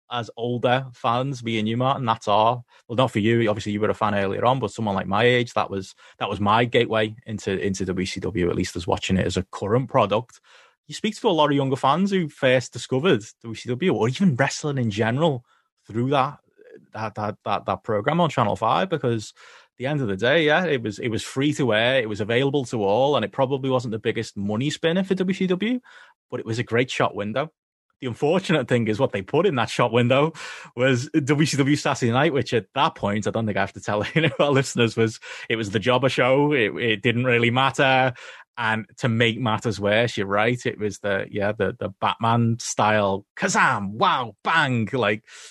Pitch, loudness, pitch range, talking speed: 120 Hz, -22 LUFS, 105-135 Hz, 220 wpm